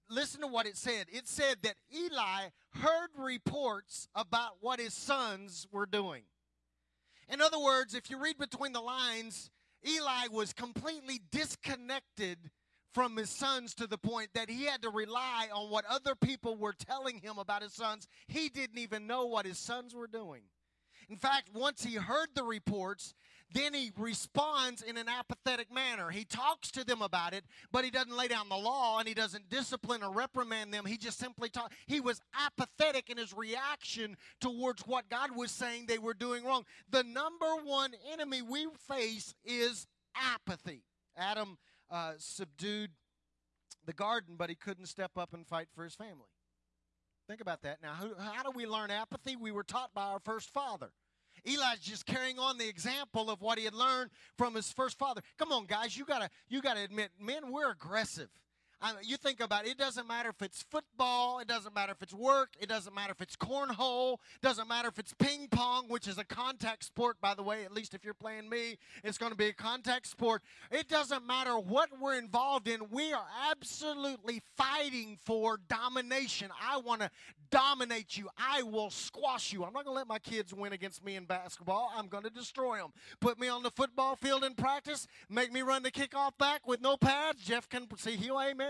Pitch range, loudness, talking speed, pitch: 210-265 Hz, -36 LUFS, 195 wpm, 235 Hz